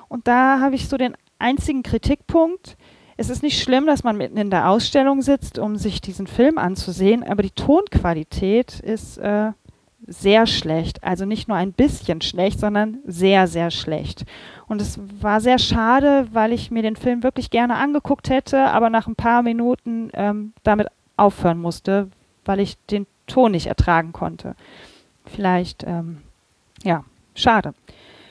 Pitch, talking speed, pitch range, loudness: 215 Hz, 160 wpm, 190-255 Hz, -19 LUFS